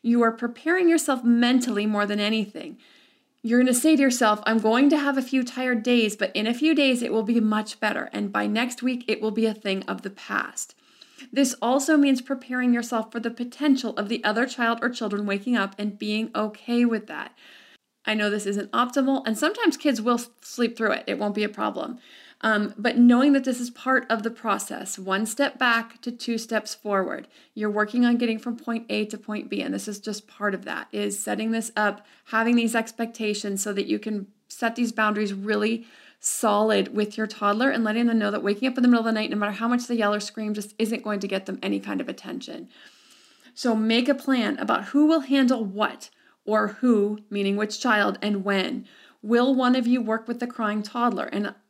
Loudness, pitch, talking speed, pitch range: -24 LUFS, 230 Hz, 225 wpm, 210-250 Hz